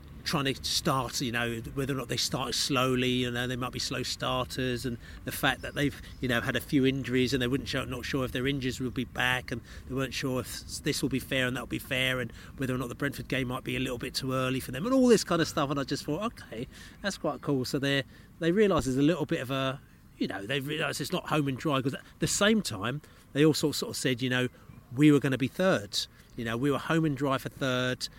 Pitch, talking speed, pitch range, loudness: 130 Hz, 285 wpm, 125-145 Hz, -29 LUFS